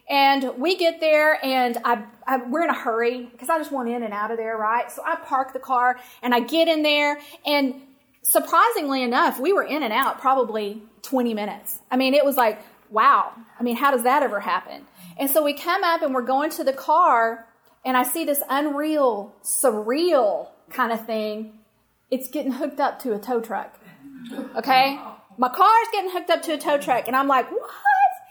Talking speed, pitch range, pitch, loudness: 205 wpm, 240-305 Hz, 265 Hz, -22 LUFS